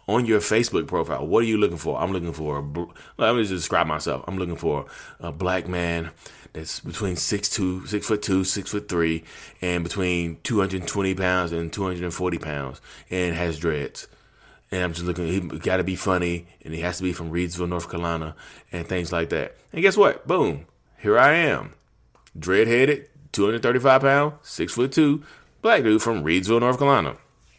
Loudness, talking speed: -23 LUFS, 200 wpm